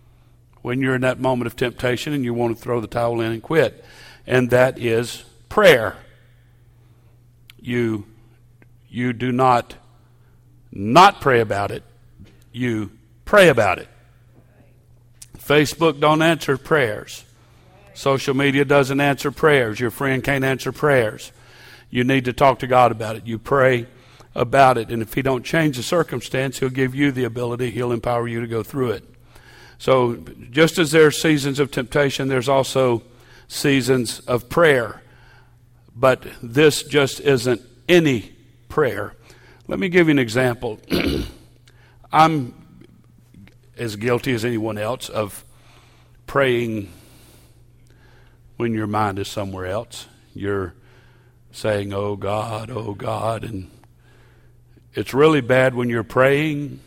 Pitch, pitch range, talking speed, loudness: 120 Hz, 120-130 Hz, 135 wpm, -19 LUFS